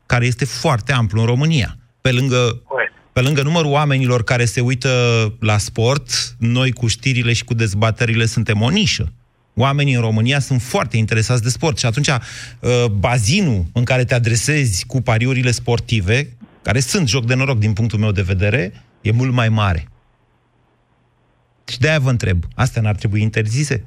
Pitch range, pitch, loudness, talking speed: 115-130 Hz, 120 Hz, -17 LUFS, 170 wpm